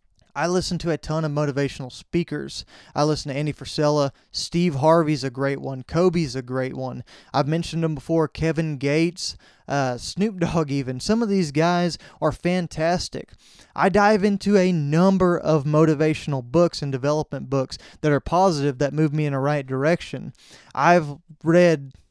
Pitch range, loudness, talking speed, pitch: 140-170 Hz, -22 LUFS, 165 wpm, 155 Hz